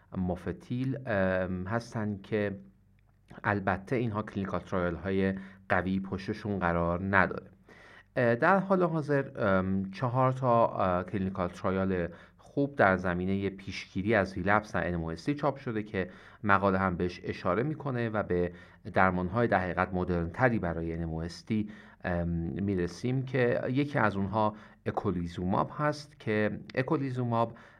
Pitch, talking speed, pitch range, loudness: 100 Hz, 115 wpm, 90-115 Hz, -30 LUFS